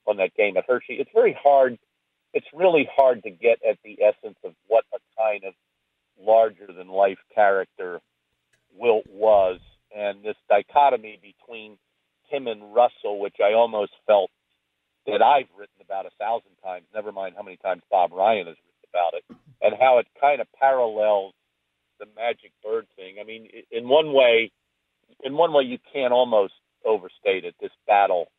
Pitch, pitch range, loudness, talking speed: 110 Hz, 95-150 Hz, -22 LUFS, 170 wpm